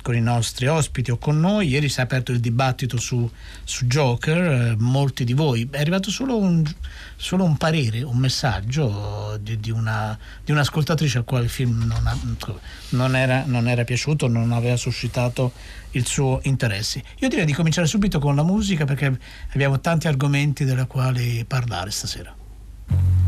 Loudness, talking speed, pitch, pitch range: -22 LUFS, 175 wpm, 130 Hz, 115-145 Hz